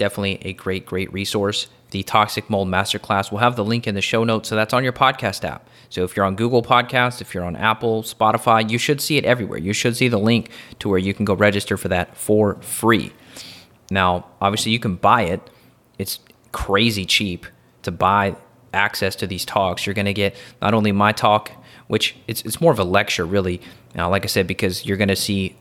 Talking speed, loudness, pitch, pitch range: 220 wpm, -20 LUFS, 100 Hz, 95-115 Hz